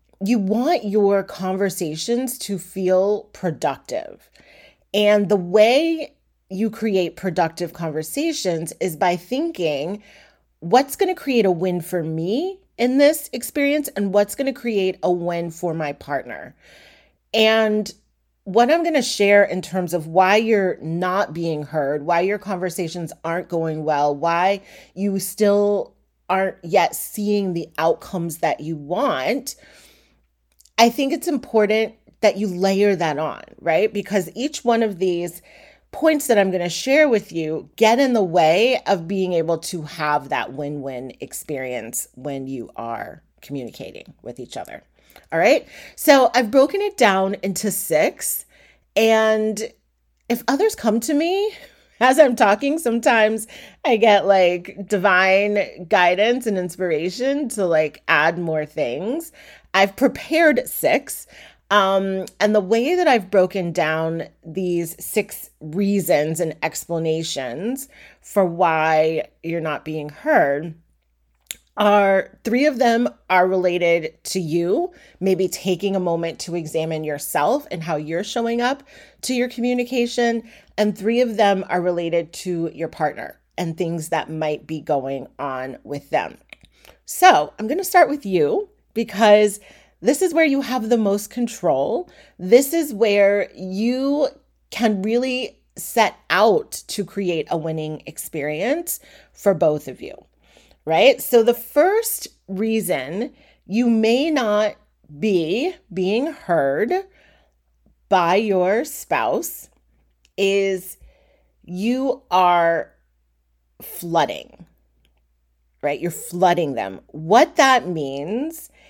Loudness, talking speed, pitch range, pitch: -20 LUFS, 135 wpm, 170-235 Hz, 195 Hz